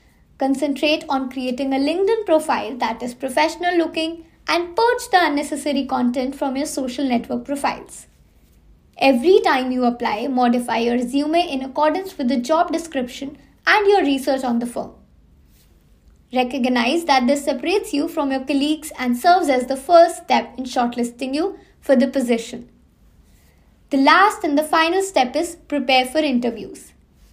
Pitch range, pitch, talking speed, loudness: 255-320 Hz, 280 Hz, 150 wpm, -19 LUFS